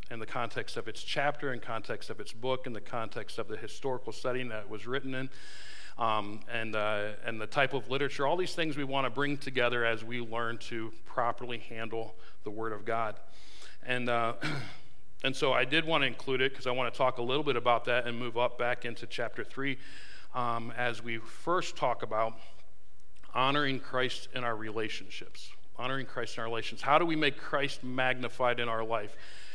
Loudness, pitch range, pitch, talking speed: -33 LUFS, 115-135 Hz, 120 Hz, 205 wpm